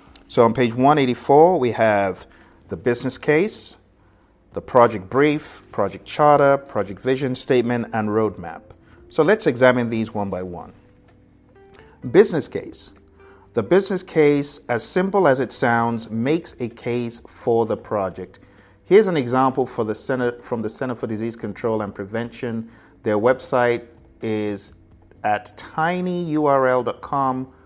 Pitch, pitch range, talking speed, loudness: 120 Hz, 105-135 Hz, 125 wpm, -20 LUFS